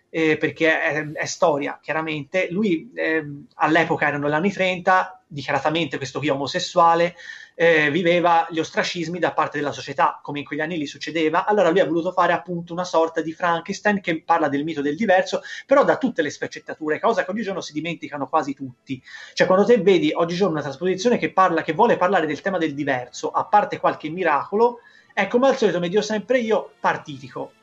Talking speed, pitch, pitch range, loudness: 190 wpm, 170 Hz, 155-185 Hz, -21 LUFS